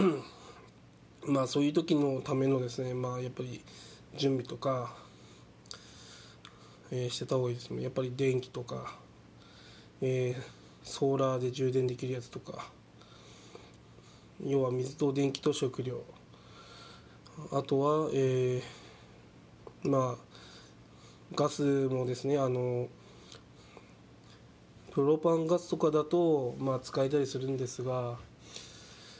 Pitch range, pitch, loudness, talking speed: 125-140 Hz, 130 Hz, -32 LUFS, 220 characters per minute